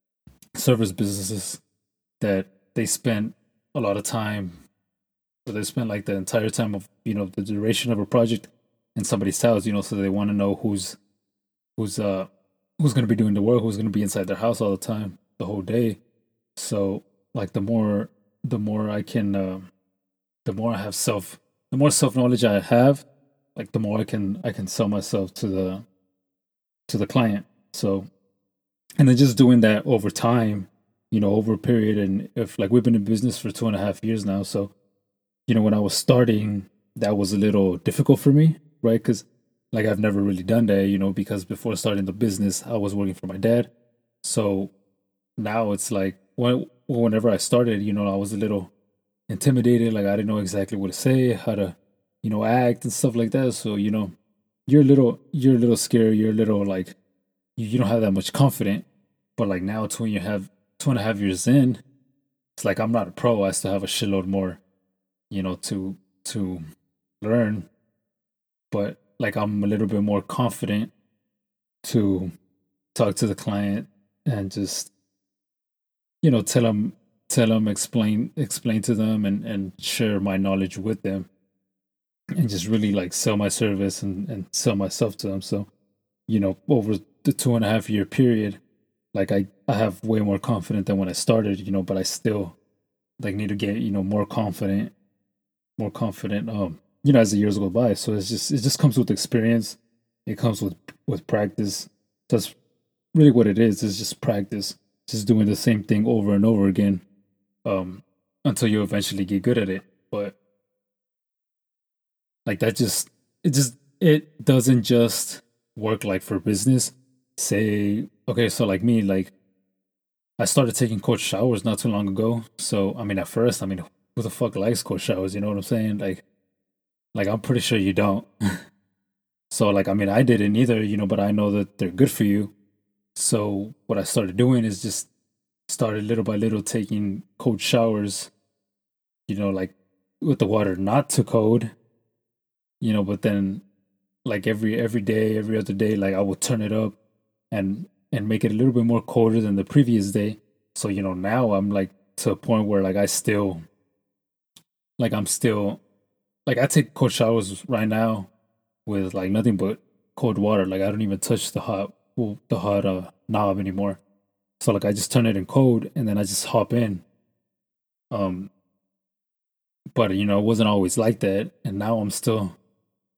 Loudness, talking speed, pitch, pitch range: -23 LUFS, 190 wpm, 105 Hz, 100-115 Hz